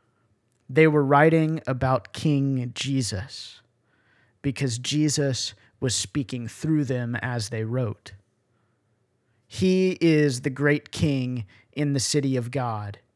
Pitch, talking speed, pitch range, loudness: 130 Hz, 115 wpm, 115-145 Hz, -24 LUFS